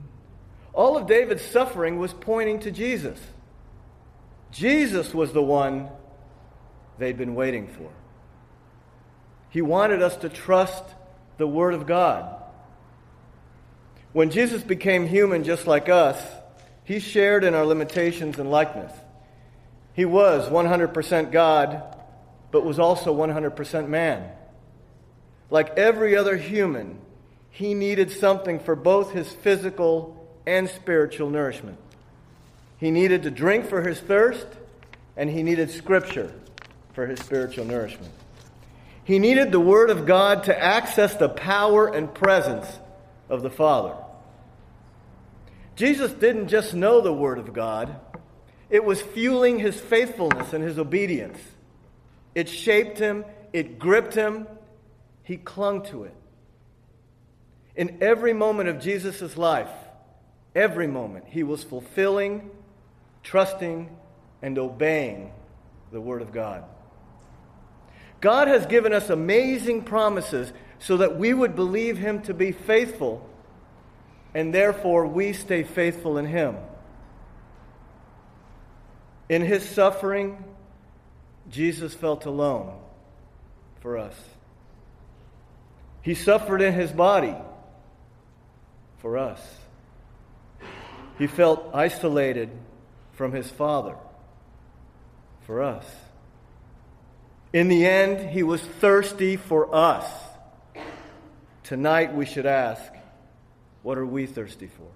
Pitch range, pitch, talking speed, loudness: 125-195 Hz, 165 Hz, 115 wpm, -22 LUFS